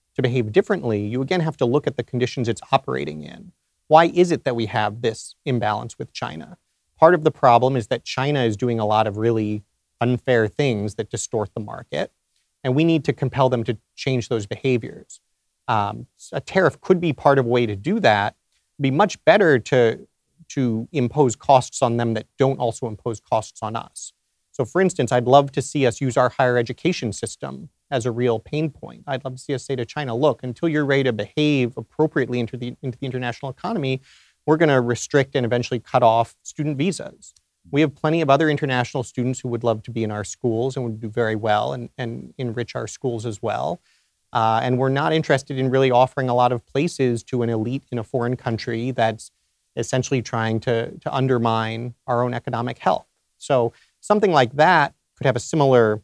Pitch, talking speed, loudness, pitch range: 125 Hz, 210 wpm, -21 LUFS, 115-140 Hz